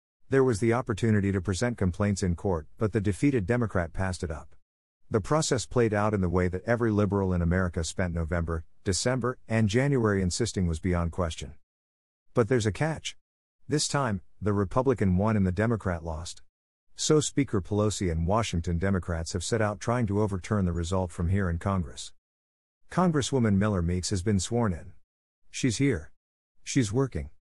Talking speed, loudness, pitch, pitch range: 170 wpm, -28 LUFS, 100 Hz, 85-115 Hz